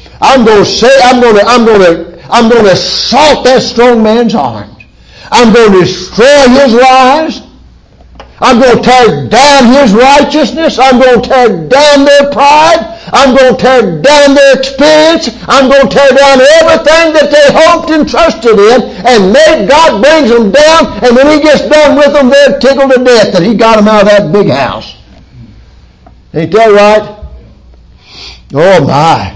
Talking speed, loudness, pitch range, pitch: 175 wpm, -4 LUFS, 225-285 Hz, 260 Hz